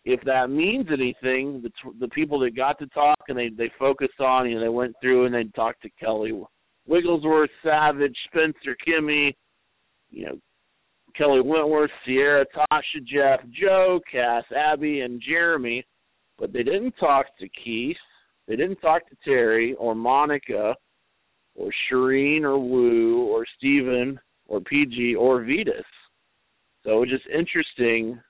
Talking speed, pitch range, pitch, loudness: 155 wpm, 125-150 Hz, 135 Hz, -23 LUFS